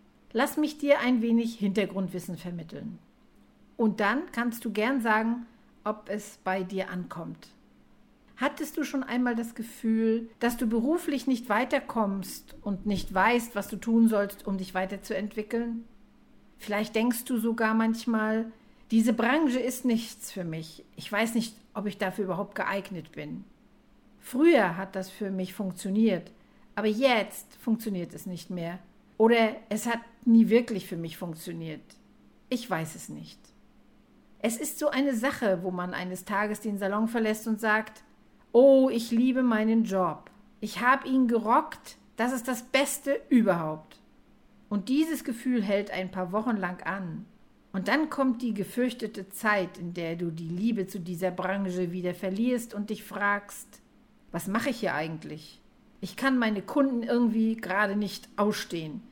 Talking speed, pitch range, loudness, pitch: 155 wpm, 195-235 Hz, -28 LUFS, 215 Hz